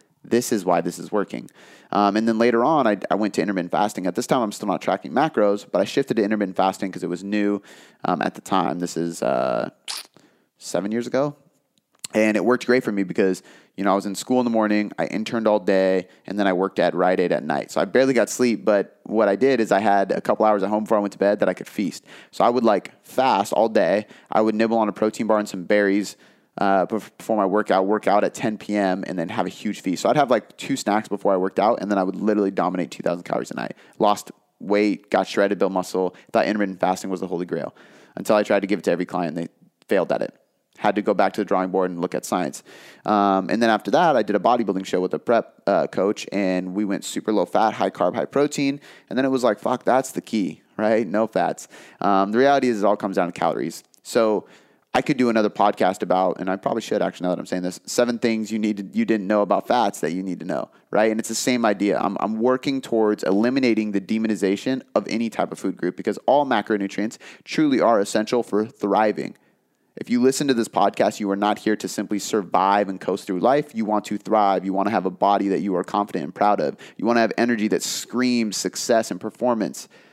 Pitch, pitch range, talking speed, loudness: 105 Hz, 95-115 Hz, 255 wpm, -22 LUFS